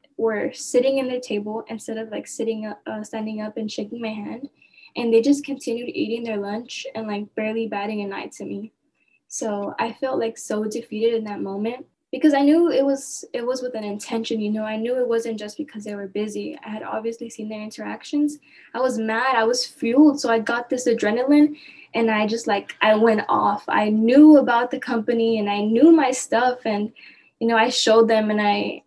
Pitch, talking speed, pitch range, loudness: 230 Hz, 215 wpm, 215-260 Hz, -21 LUFS